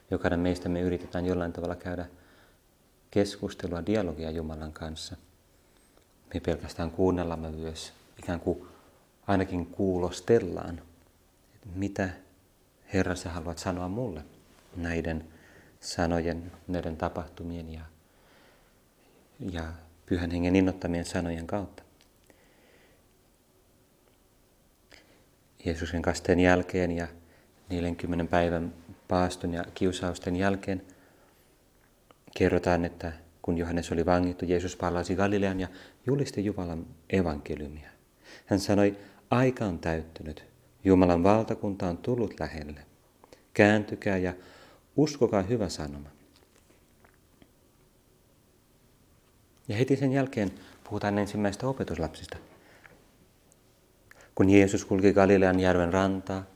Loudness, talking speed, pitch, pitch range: -29 LUFS, 95 wpm, 90 Hz, 85-95 Hz